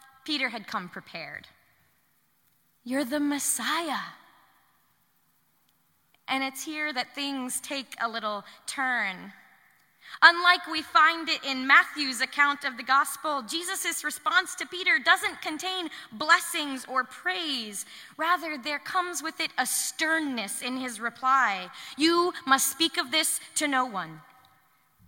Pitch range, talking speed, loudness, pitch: 255-330 Hz, 125 wpm, -26 LUFS, 285 Hz